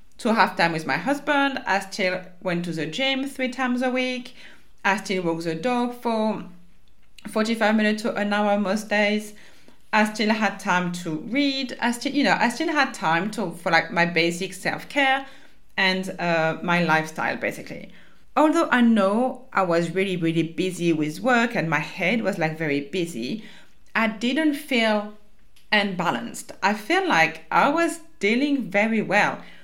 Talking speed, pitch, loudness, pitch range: 170 wpm, 205 Hz, -23 LUFS, 175-250 Hz